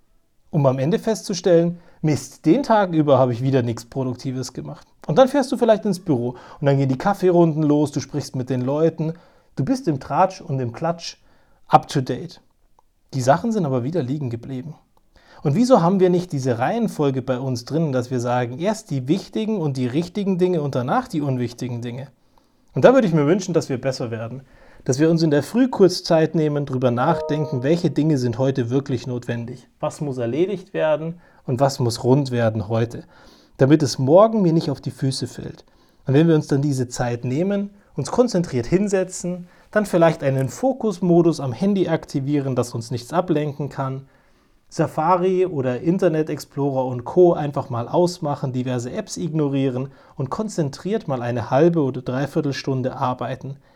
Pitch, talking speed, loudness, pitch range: 145 Hz, 180 wpm, -21 LUFS, 130-175 Hz